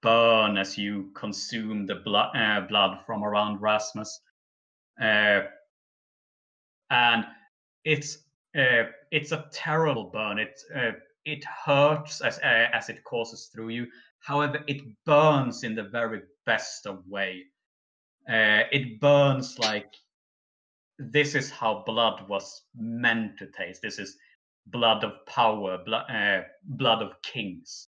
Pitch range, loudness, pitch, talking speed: 105-150 Hz, -26 LUFS, 120 Hz, 130 wpm